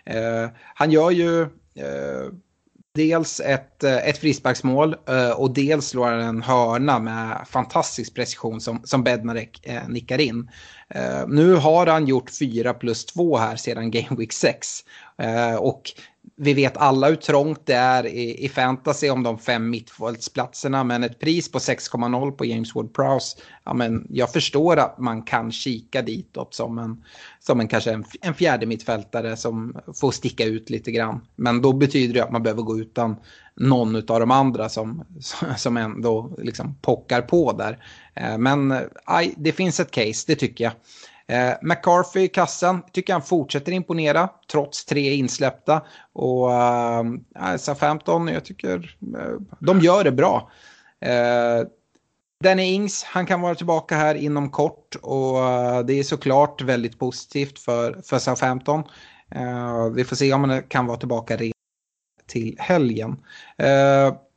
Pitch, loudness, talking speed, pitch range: 130 Hz, -22 LUFS, 155 wpm, 115-150 Hz